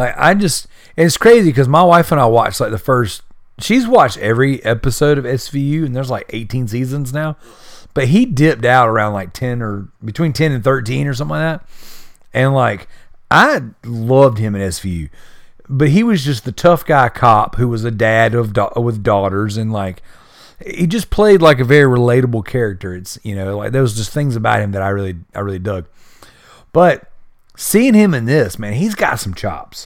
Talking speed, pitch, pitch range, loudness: 200 wpm, 125 Hz, 105-150 Hz, -14 LUFS